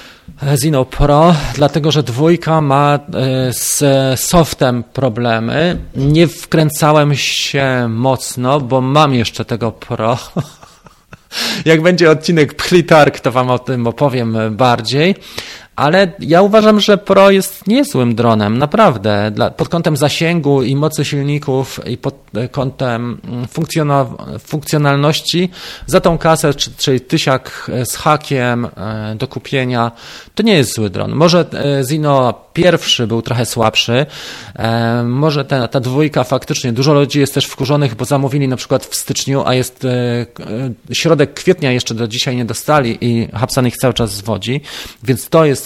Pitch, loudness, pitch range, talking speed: 135 Hz, -13 LUFS, 120-155 Hz, 135 wpm